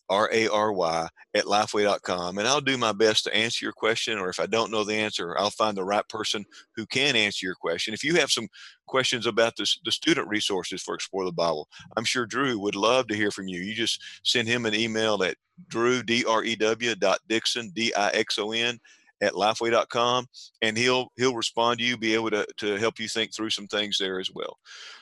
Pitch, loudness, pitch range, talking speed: 110 Hz, -25 LUFS, 105-120 Hz, 205 wpm